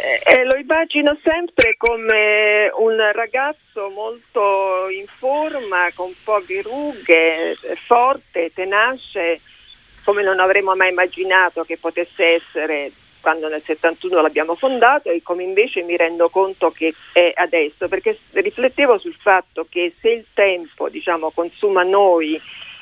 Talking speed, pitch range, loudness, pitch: 125 wpm, 170-245 Hz, -17 LUFS, 190 Hz